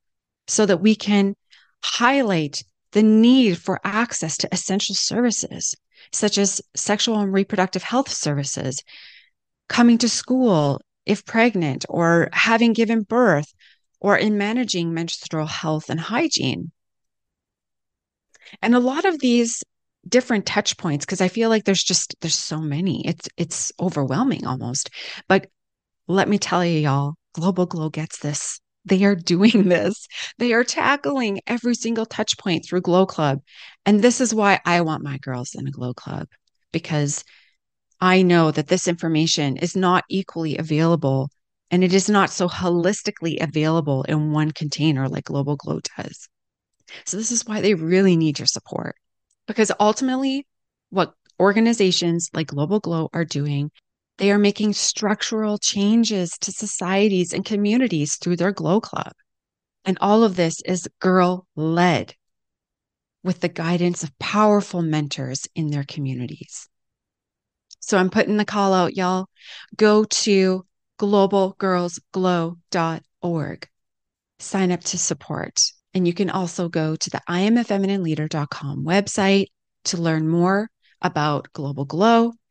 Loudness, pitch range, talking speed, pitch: -20 LUFS, 155-205 Hz, 140 wpm, 185 Hz